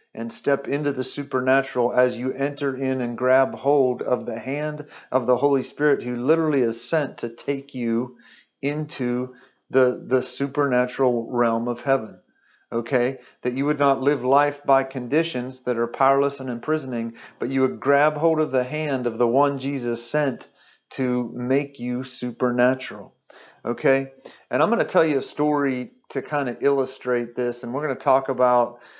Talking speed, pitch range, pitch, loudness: 170 wpm, 125-140 Hz, 130 Hz, -23 LUFS